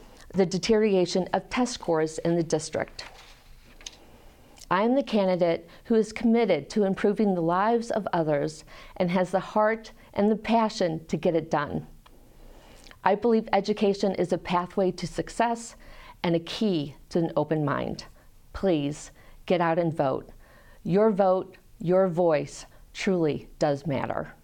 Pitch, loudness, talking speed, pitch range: 185 Hz, -26 LUFS, 145 wpm, 165-210 Hz